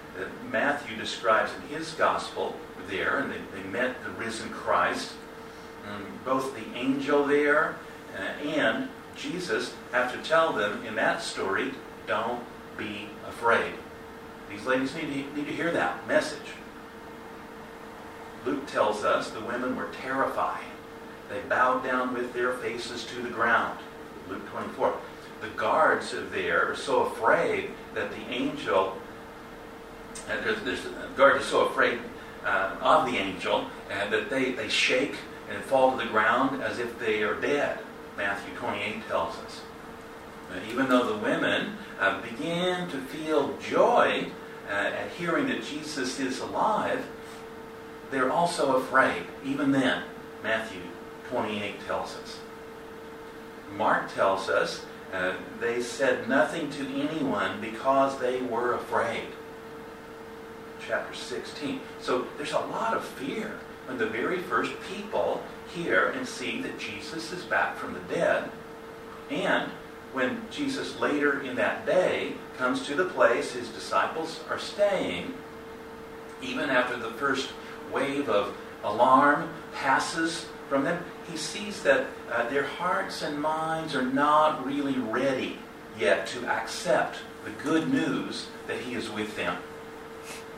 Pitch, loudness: 155 Hz, -28 LUFS